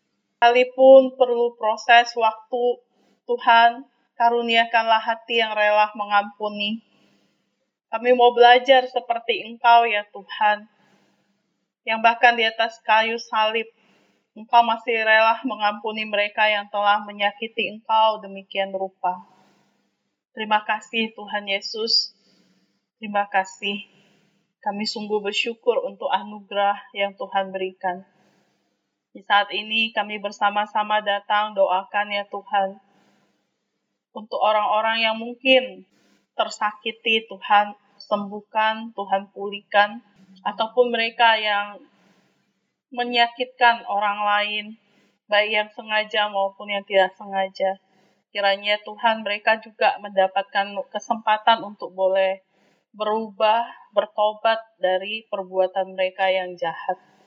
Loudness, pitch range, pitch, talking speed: -21 LUFS, 200-230 Hz, 210 Hz, 100 wpm